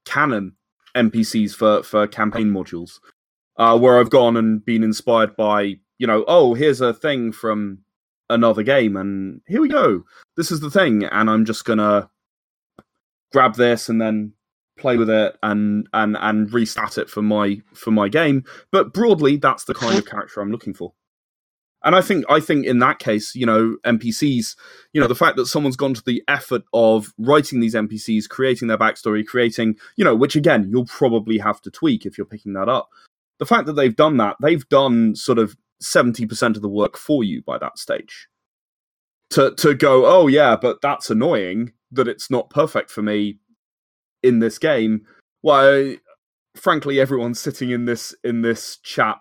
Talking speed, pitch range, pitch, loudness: 185 wpm, 105-125 Hz, 115 Hz, -18 LUFS